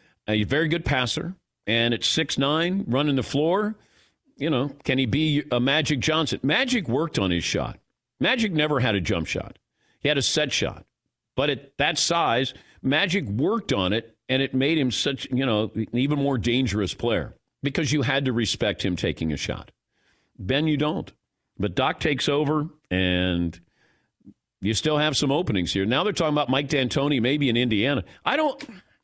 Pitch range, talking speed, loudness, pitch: 115-150 Hz, 185 wpm, -24 LUFS, 135 Hz